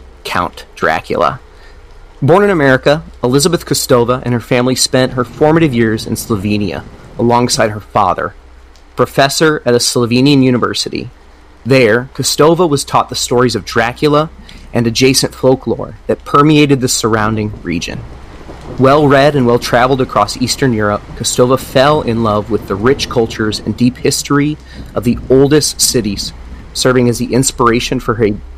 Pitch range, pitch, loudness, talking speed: 110-135 Hz, 120 Hz, -12 LUFS, 140 wpm